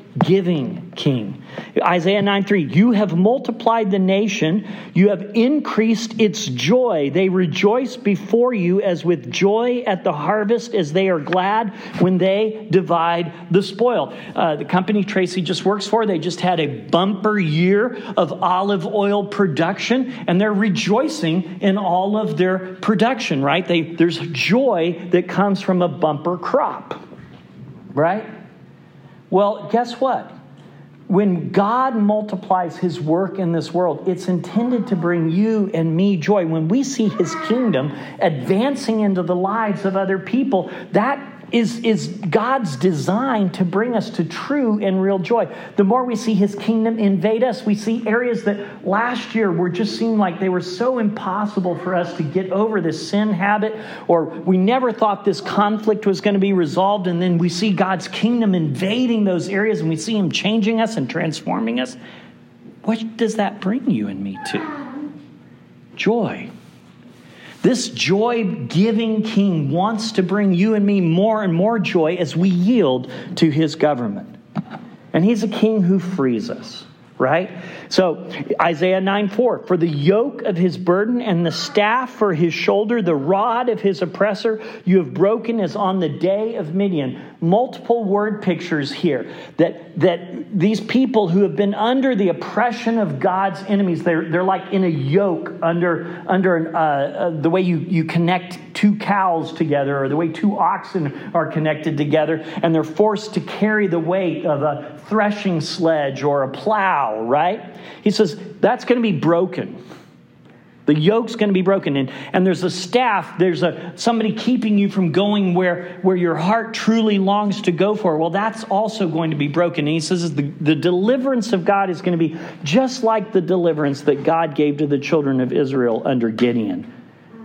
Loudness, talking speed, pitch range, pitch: -19 LUFS, 170 wpm, 170-215 Hz, 190 Hz